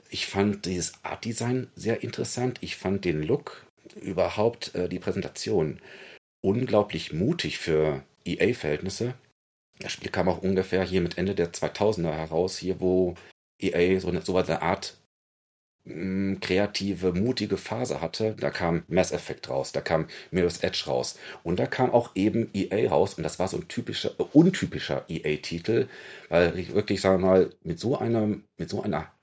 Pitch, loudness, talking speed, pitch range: 95 Hz, -27 LUFS, 165 wpm, 90-105 Hz